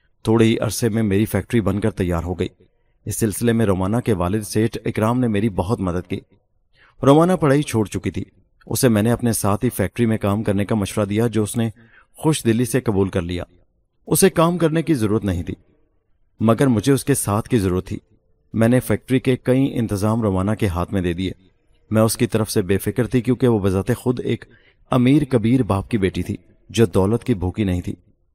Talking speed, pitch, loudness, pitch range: 220 wpm, 110 Hz, -20 LUFS, 95-120 Hz